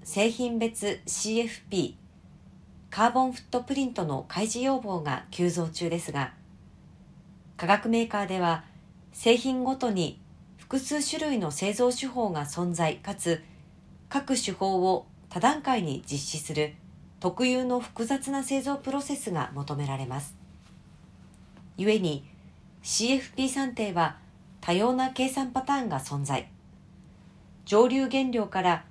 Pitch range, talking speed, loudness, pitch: 170-260 Hz, 235 characters per minute, -28 LUFS, 210 Hz